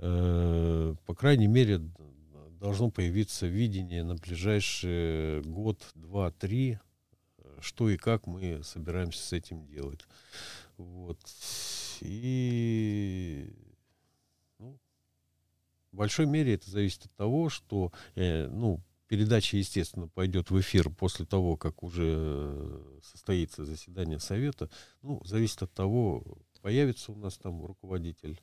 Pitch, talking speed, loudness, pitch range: 90 Hz, 110 wpm, -32 LUFS, 80-105 Hz